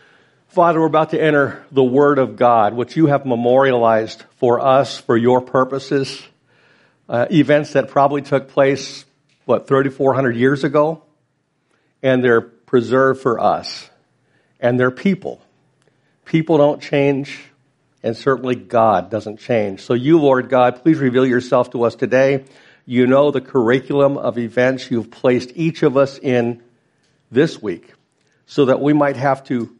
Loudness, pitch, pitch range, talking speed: -16 LUFS, 135 Hz, 125-145 Hz, 150 wpm